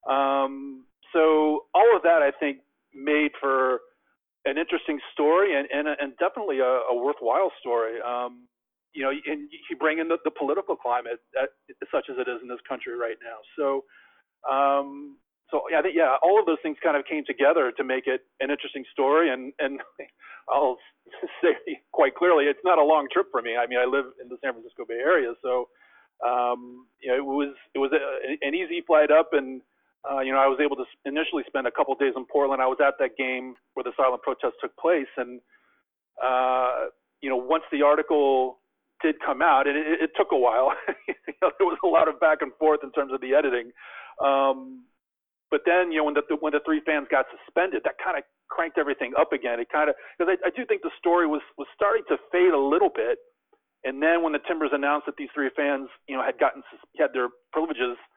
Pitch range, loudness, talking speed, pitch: 130-165 Hz, -25 LUFS, 215 wpm, 145 Hz